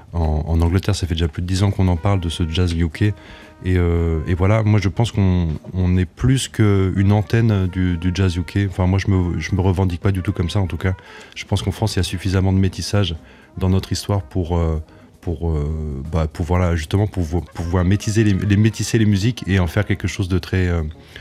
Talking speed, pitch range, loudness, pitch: 235 wpm, 85-100 Hz, -19 LUFS, 95 Hz